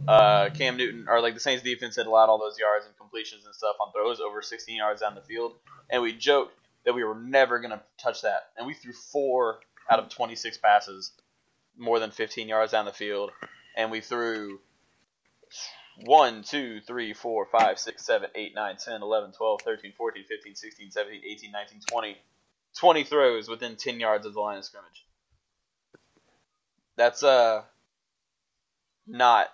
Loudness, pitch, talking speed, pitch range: -26 LUFS, 115 Hz, 175 wpm, 105-125 Hz